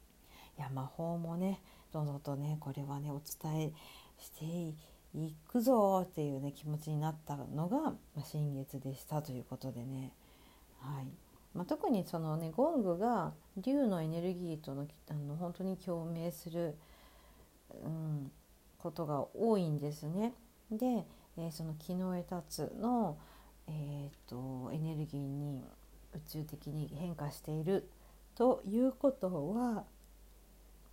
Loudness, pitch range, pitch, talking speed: -39 LUFS, 145-185 Hz, 155 Hz, 250 characters per minute